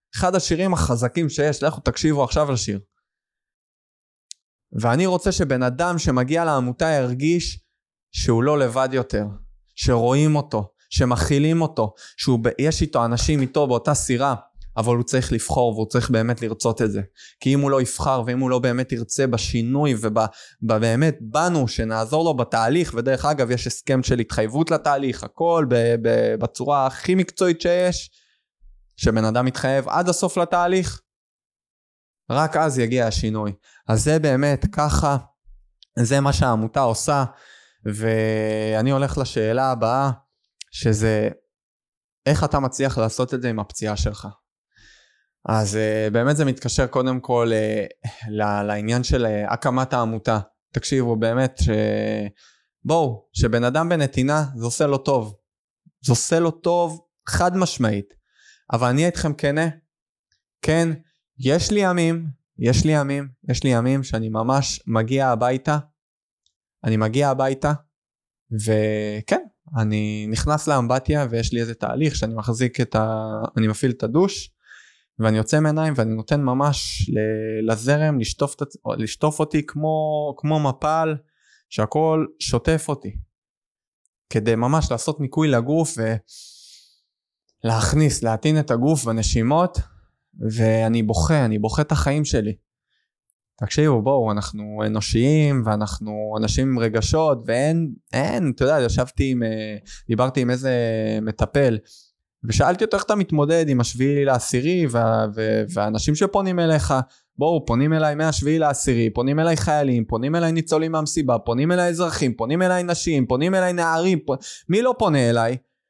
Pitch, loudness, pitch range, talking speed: 130 Hz, -21 LUFS, 110-150 Hz, 130 wpm